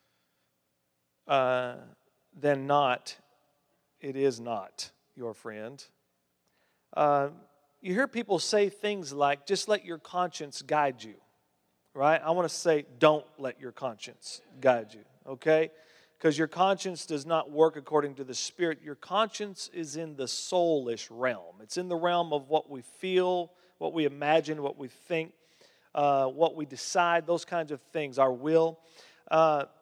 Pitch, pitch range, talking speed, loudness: 150 Hz, 130-170 Hz, 150 wpm, -29 LUFS